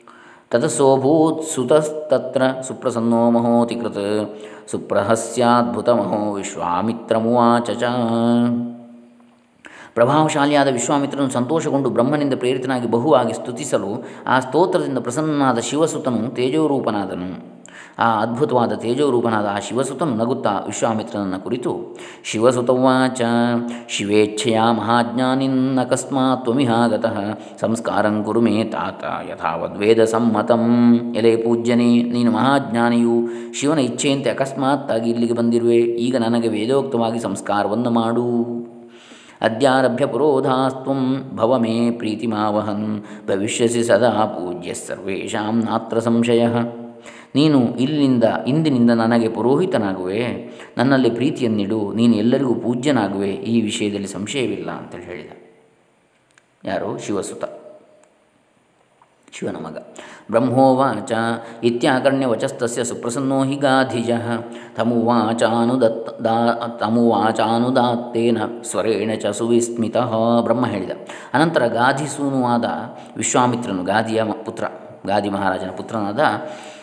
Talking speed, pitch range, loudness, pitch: 80 wpm, 115-130 Hz, -19 LUFS, 120 Hz